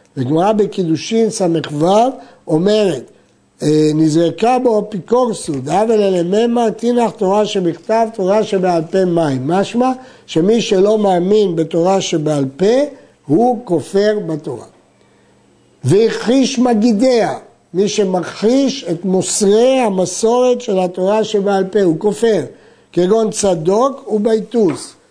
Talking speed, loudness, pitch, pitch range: 105 wpm, -14 LUFS, 200 Hz, 170-225 Hz